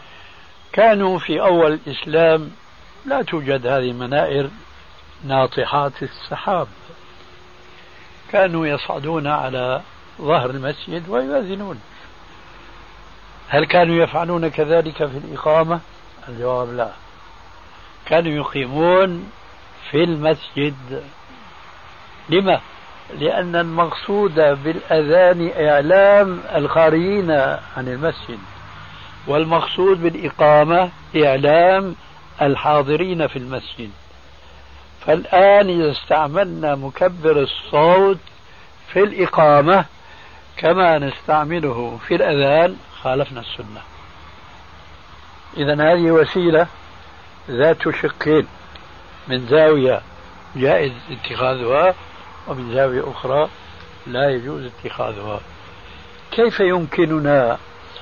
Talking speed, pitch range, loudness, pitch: 75 wpm, 115-165 Hz, -17 LUFS, 145 Hz